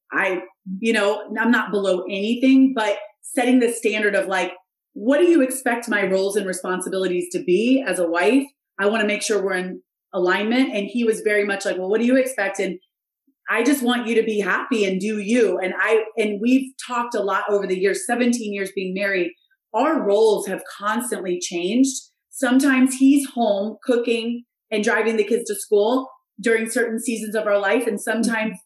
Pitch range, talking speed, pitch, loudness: 195-245 Hz, 195 wpm, 215 Hz, -20 LUFS